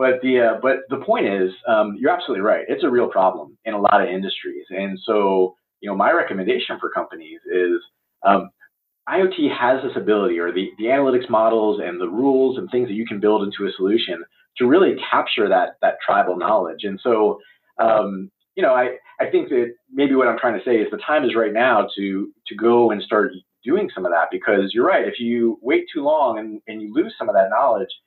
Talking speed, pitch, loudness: 220 wpm, 125 Hz, -19 LUFS